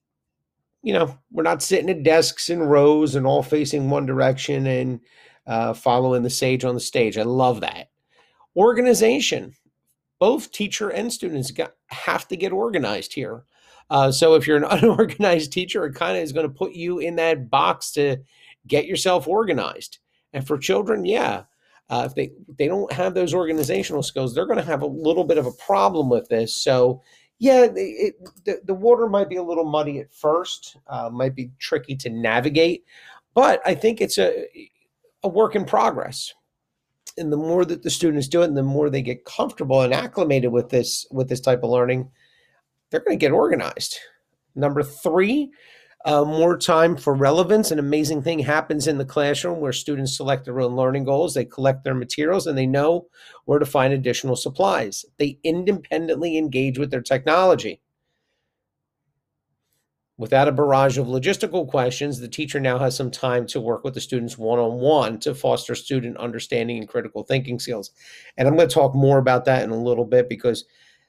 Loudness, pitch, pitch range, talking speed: -21 LUFS, 145 Hz, 130-170 Hz, 185 wpm